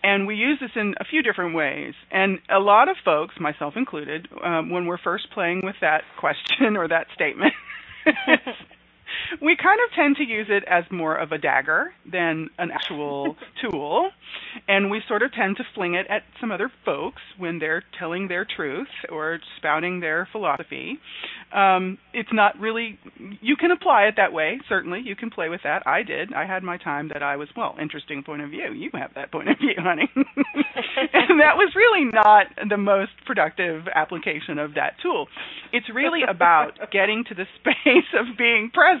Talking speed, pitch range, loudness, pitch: 190 wpm, 175-270 Hz, -22 LUFS, 200 Hz